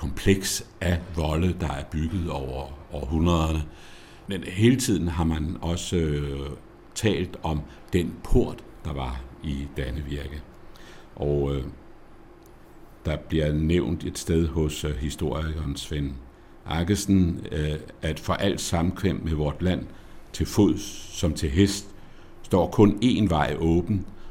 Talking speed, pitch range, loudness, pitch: 130 wpm, 75-90 Hz, -26 LUFS, 80 Hz